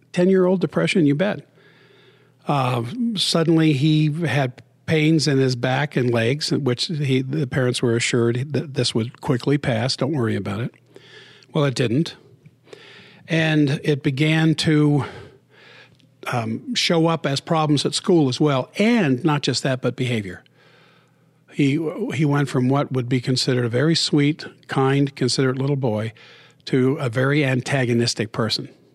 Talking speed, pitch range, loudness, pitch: 150 wpm, 130-155 Hz, -20 LUFS, 140 Hz